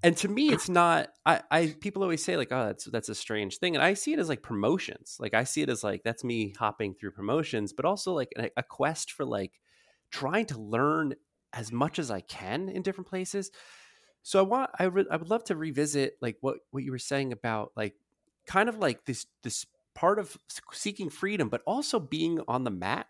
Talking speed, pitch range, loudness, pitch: 225 wpm, 115-185 Hz, -30 LUFS, 150 Hz